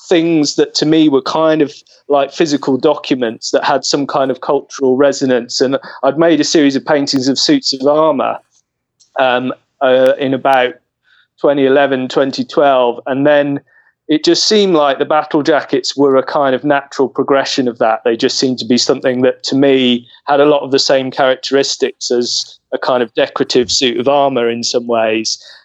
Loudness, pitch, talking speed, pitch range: -13 LUFS, 140 Hz, 180 wpm, 130-150 Hz